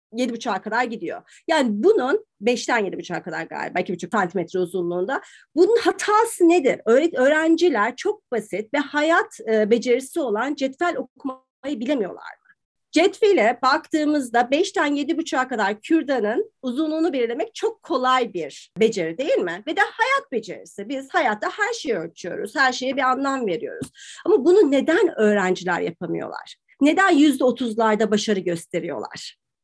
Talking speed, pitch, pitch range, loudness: 130 wpm, 270 Hz, 225-340 Hz, -21 LUFS